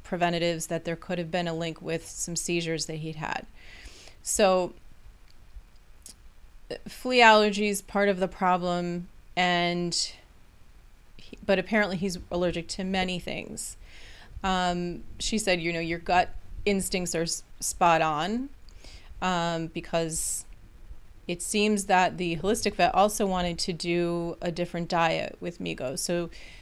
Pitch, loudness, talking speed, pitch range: 175 Hz, -27 LUFS, 135 wpm, 165-190 Hz